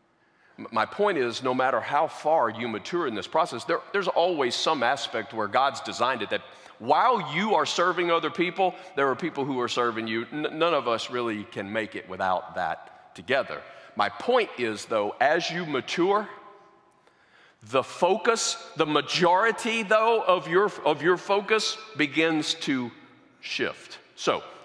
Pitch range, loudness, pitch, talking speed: 140-205 Hz, -26 LUFS, 170 Hz, 165 wpm